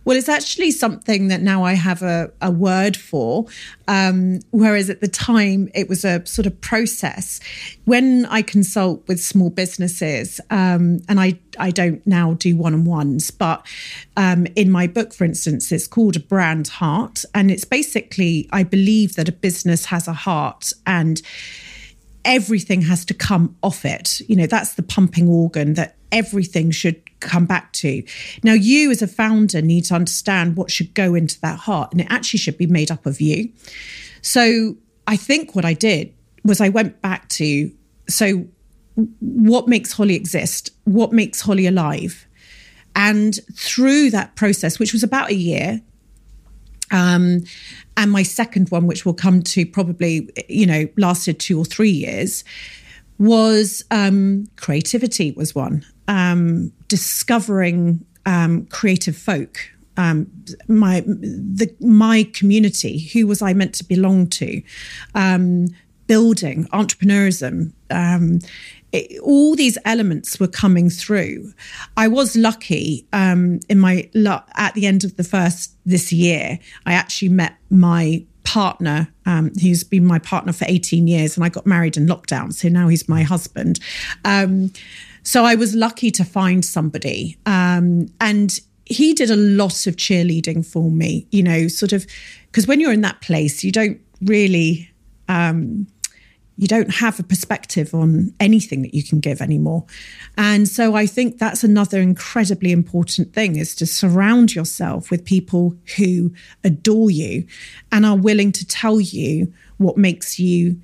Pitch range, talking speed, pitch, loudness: 170-210 Hz, 155 wpm, 185 Hz, -17 LUFS